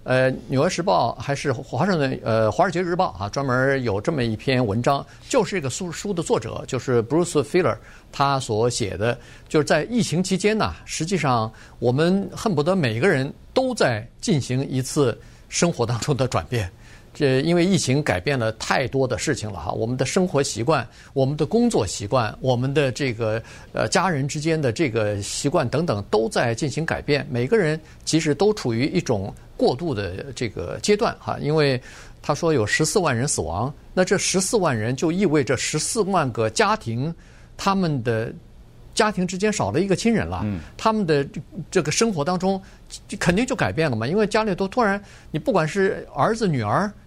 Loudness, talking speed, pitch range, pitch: -22 LUFS, 290 characters per minute, 120-180 Hz, 145 Hz